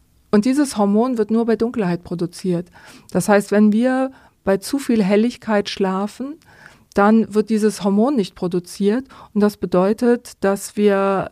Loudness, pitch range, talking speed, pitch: -19 LUFS, 195-230 Hz, 150 wpm, 210 Hz